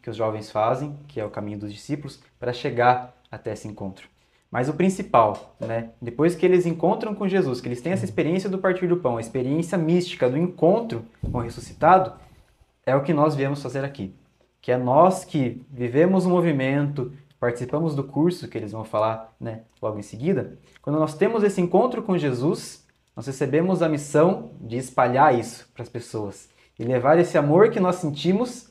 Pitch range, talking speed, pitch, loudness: 120-170 Hz, 190 wpm, 140 Hz, -23 LUFS